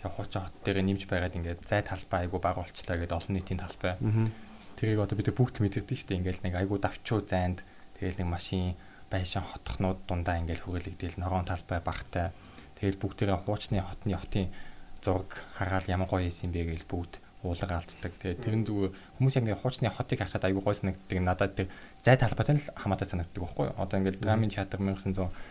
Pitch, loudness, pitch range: 95 Hz, -32 LUFS, 90-100 Hz